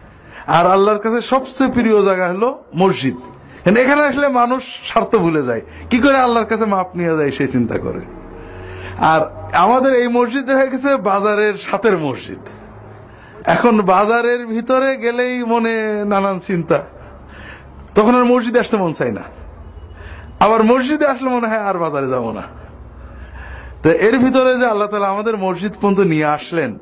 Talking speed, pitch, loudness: 140 wpm, 205 Hz, -15 LUFS